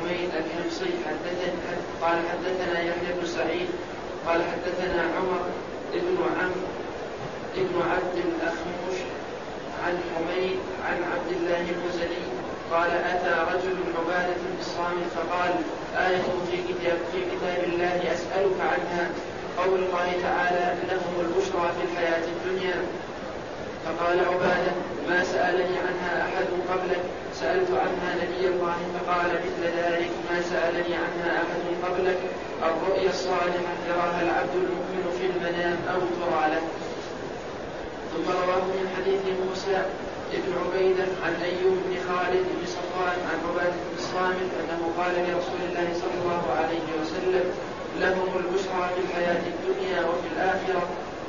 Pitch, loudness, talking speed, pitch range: 175 Hz, -27 LUFS, 120 wpm, 175-180 Hz